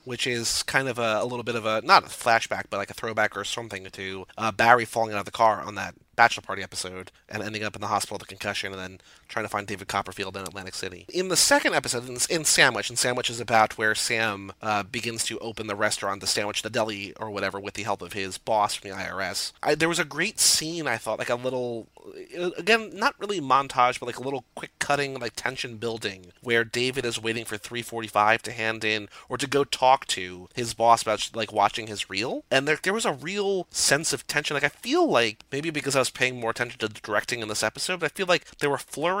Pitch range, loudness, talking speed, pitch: 105-135 Hz, -25 LUFS, 250 wpm, 115 Hz